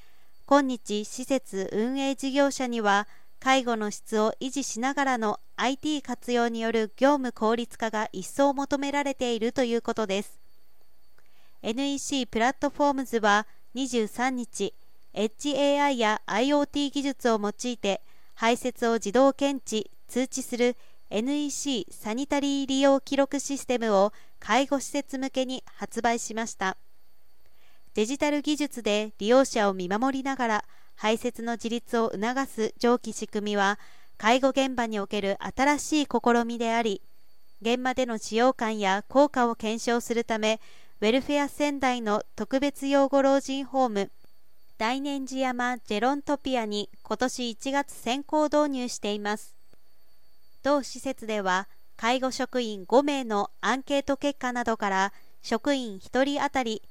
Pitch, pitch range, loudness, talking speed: 245 Hz, 220-275 Hz, -27 LUFS, 270 characters per minute